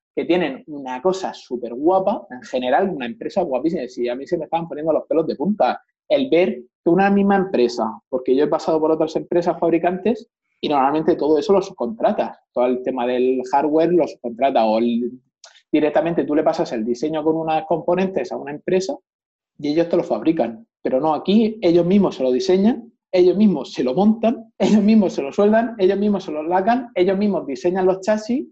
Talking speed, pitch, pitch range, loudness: 200 wpm, 175 Hz, 145-200 Hz, -19 LUFS